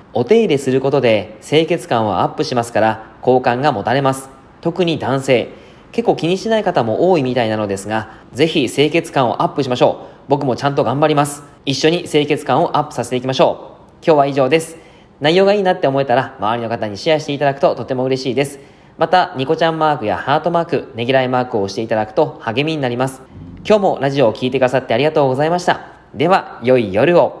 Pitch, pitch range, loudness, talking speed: 140 Hz, 125-155 Hz, -16 LUFS, 460 characters per minute